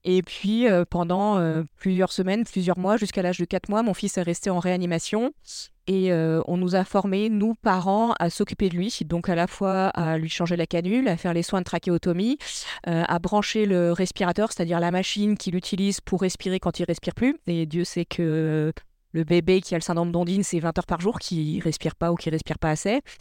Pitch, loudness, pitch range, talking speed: 180 Hz, -24 LUFS, 170-195 Hz, 230 wpm